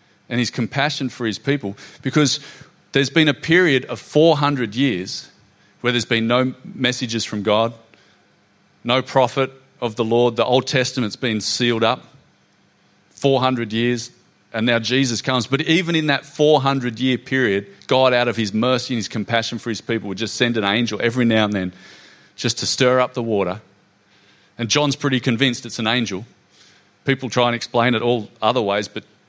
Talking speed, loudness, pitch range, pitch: 180 wpm, -19 LUFS, 110-130 Hz, 120 Hz